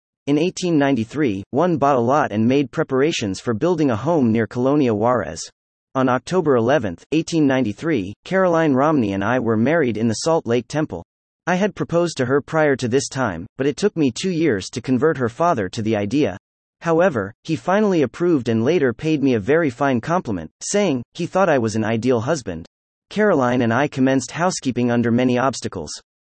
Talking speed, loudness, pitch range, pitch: 185 wpm, -19 LUFS, 115-160 Hz, 130 Hz